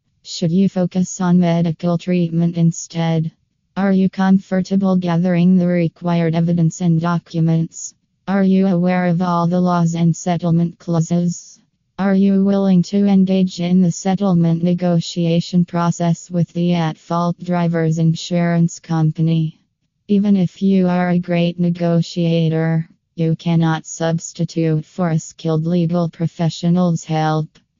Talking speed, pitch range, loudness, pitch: 125 wpm, 165-180 Hz, -17 LUFS, 170 Hz